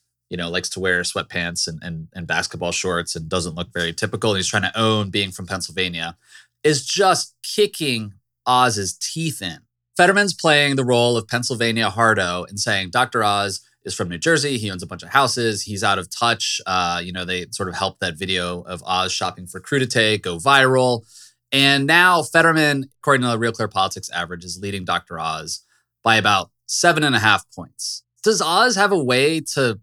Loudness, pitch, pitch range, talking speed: -19 LUFS, 110 Hz, 90-130 Hz, 195 wpm